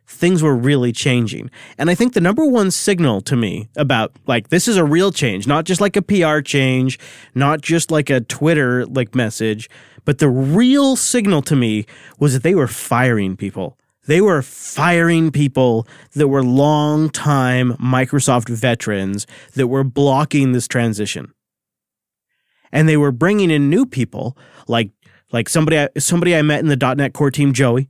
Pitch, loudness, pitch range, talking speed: 140 Hz, -16 LUFS, 125-155 Hz, 170 wpm